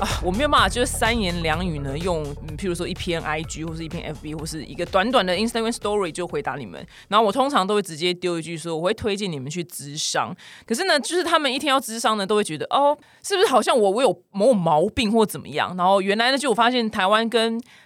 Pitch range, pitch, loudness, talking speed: 165-230 Hz, 195 Hz, -22 LUFS, 410 characters per minute